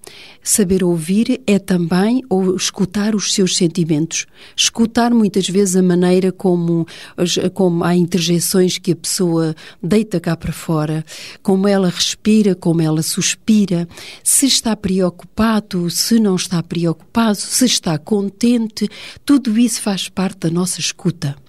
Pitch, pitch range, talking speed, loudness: 185 Hz, 175-210 Hz, 135 wpm, -16 LUFS